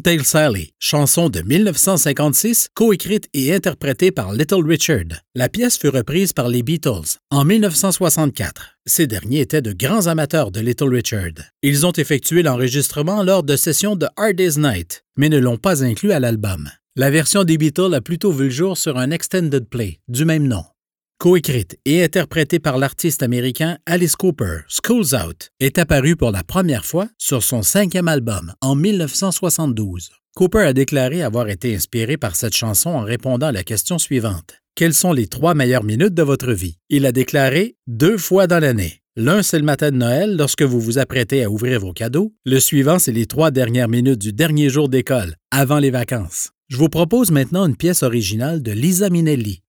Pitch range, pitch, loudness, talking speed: 120-175 Hz, 145 Hz, -17 LUFS, 185 wpm